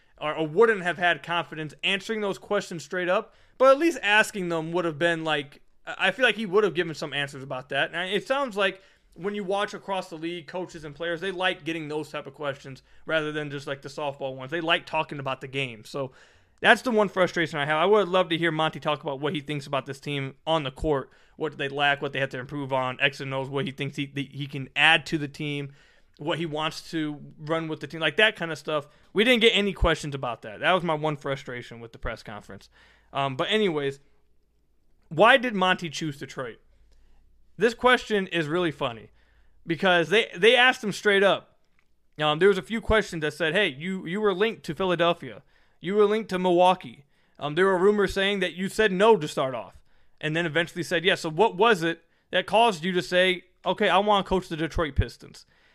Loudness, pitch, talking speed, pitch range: -25 LUFS, 165 Hz, 230 wpm, 145-195 Hz